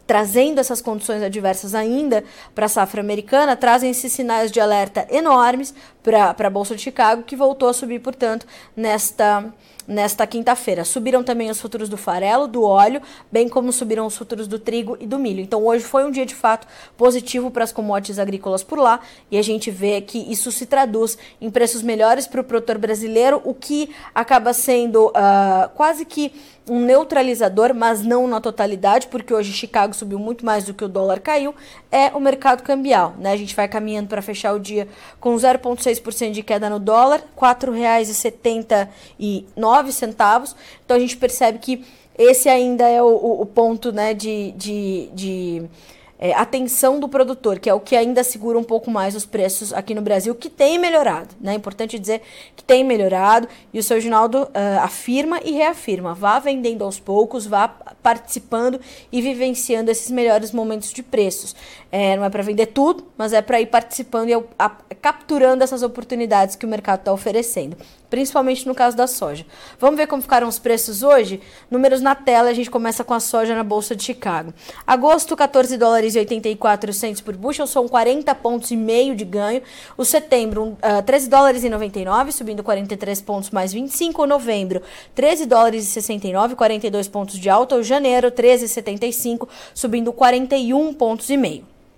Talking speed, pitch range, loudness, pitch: 175 wpm, 210-255 Hz, -18 LUFS, 235 Hz